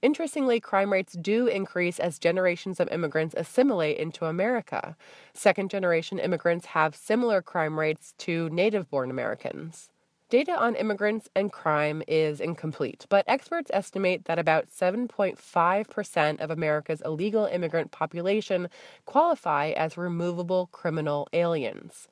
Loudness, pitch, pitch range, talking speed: -27 LUFS, 175 Hz, 160-205 Hz, 125 wpm